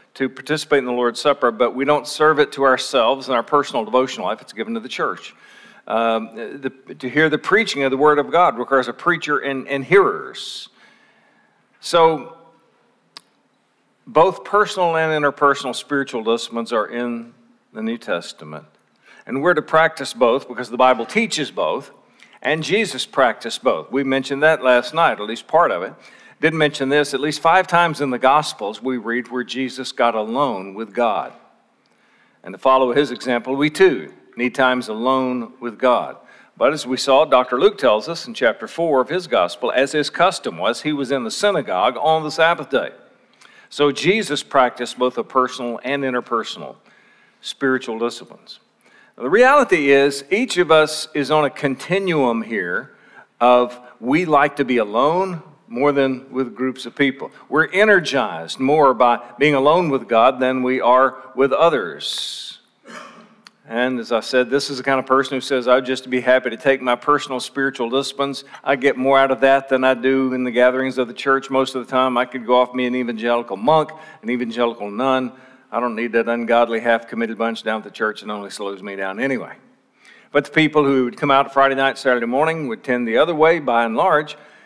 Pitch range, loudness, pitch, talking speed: 125-150 Hz, -18 LUFS, 135 Hz, 190 wpm